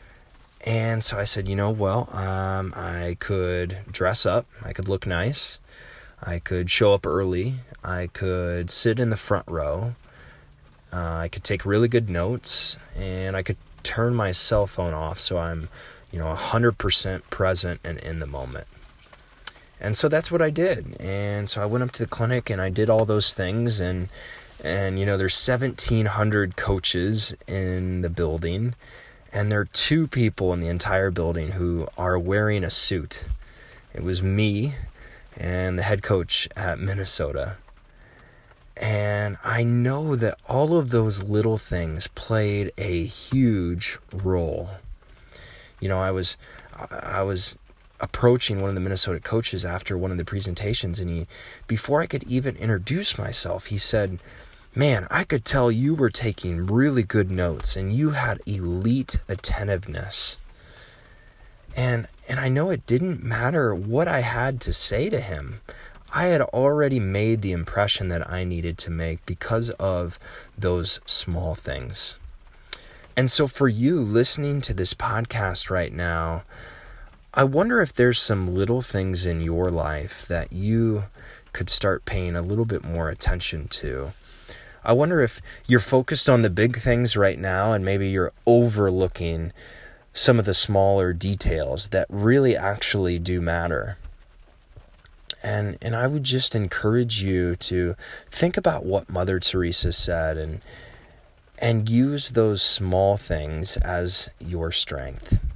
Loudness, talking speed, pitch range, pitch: -22 LUFS, 155 wpm, 90-120 Hz, 100 Hz